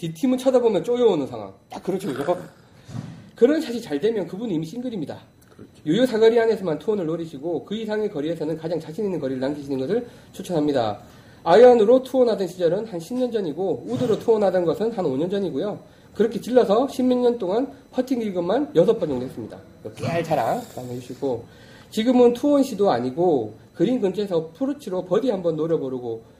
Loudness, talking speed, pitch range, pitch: -22 LUFS, 385 characters per minute, 155-240 Hz, 195 Hz